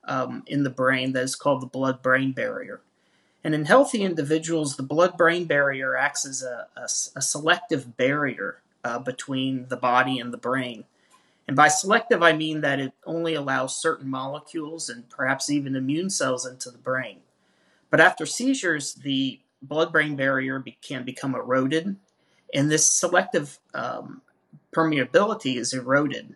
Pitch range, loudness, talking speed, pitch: 130-160 Hz, -24 LUFS, 155 wpm, 140 Hz